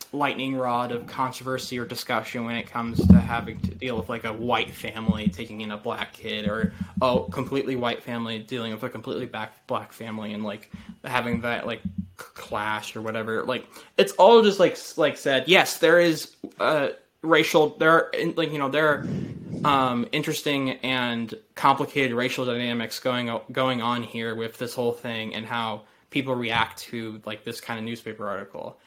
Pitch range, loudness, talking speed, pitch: 110-135 Hz, -25 LUFS, 185 wpm, 120 Hz